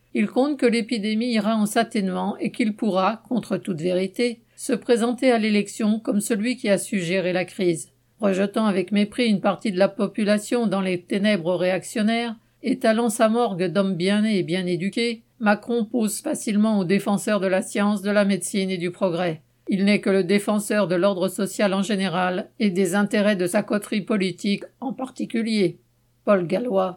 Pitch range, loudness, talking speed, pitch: 190-225 Hz, -23 LUFS, 180 wpm, 205 Hz